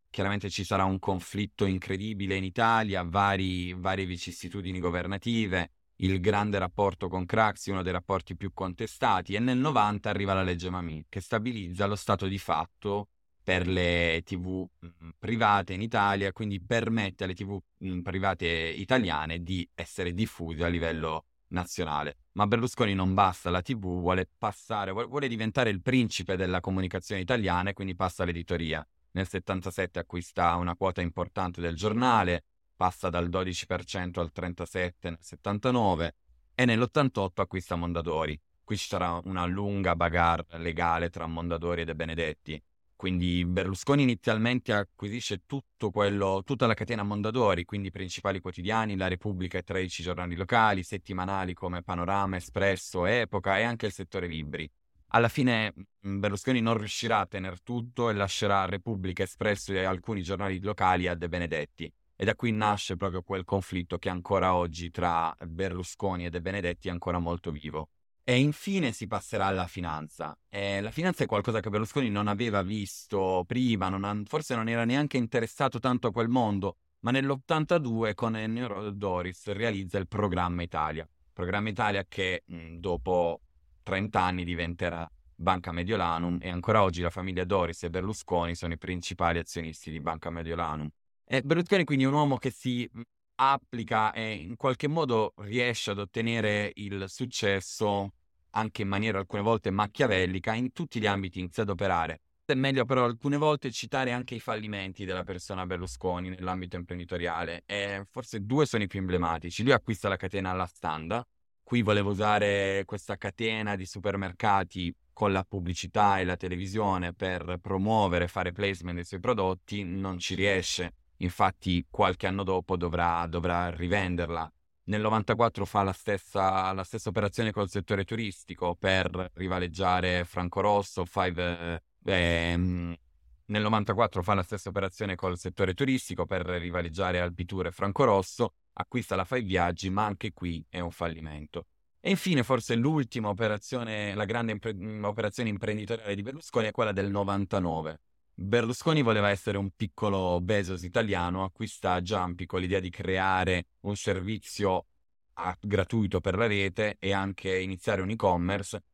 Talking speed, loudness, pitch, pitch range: 155 wpm, -30 LUFS, 95 Hz, 90-105 Hz